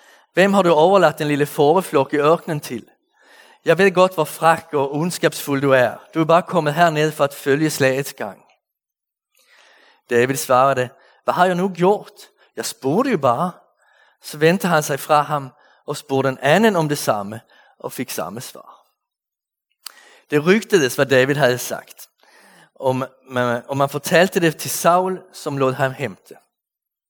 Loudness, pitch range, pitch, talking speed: -18 LUFS, 135-170 Hz, 150 Hz, 170 wpm